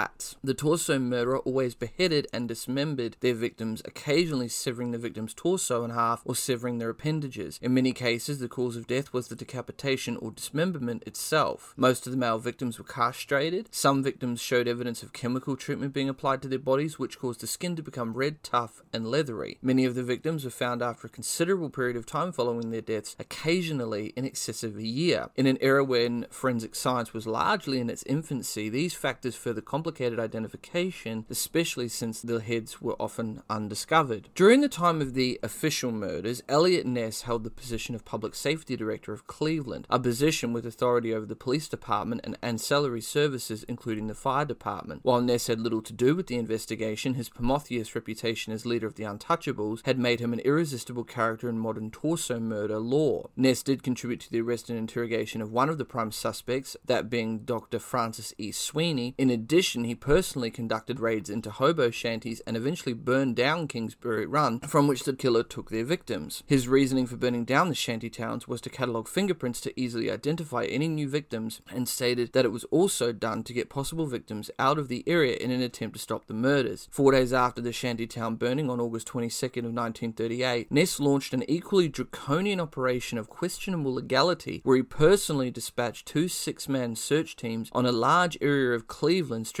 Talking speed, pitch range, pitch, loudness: 190 wpm, 115-135 Hz, 125 Hz, -28 LUFS